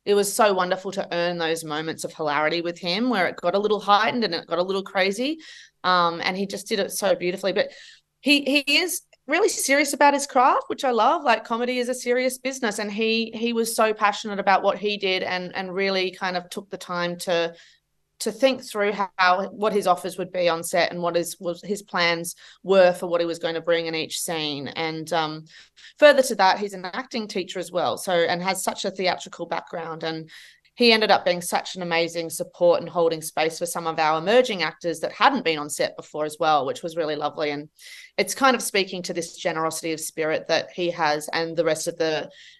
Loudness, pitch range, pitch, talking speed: -23 LUFS, 170-220 Hz, 185 Hz, 230 wpm